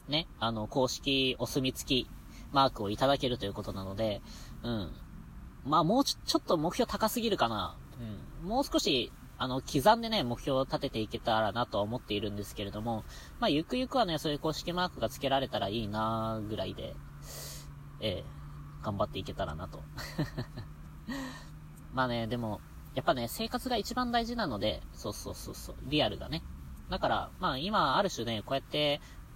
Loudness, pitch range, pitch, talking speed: -32 LUFS, 105-150 Hz, 120 Hz, 355 characters per minute